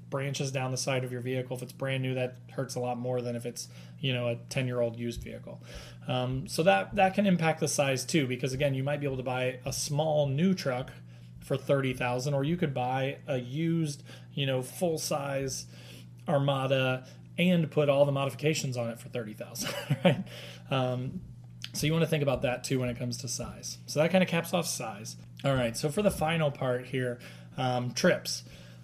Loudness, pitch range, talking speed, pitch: -30 LUFS, 120-145 Hz, 210 wpm, 130 Hz